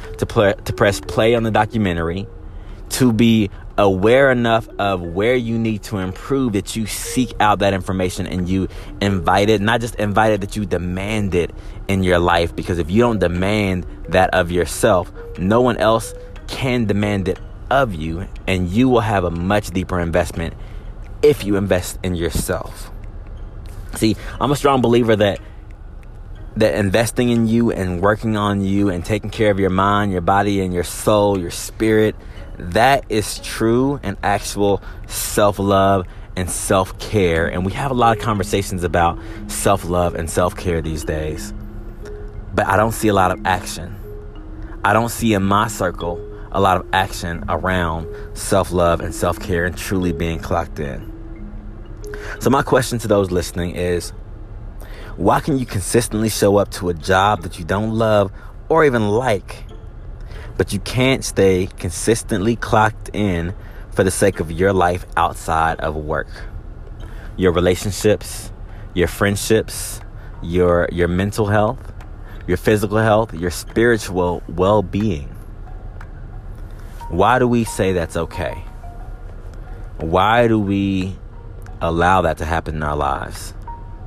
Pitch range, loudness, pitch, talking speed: 90-105 Hz, -18 LUFS, 100 Hz, 155 wpm